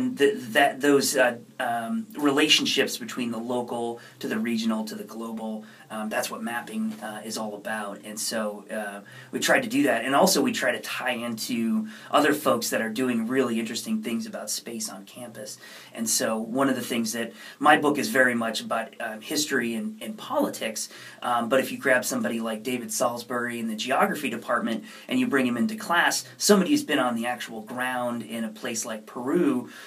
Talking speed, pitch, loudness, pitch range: 195 wpm, 120 Hz, -26 LUFS, 115-150 Hz